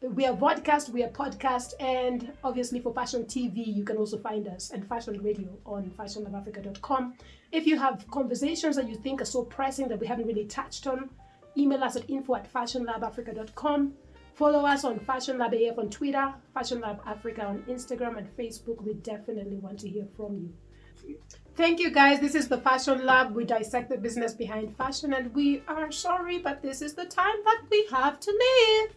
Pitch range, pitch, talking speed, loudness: 225-280 Hz, 255 Hz, 195 wpm, -28 LUFS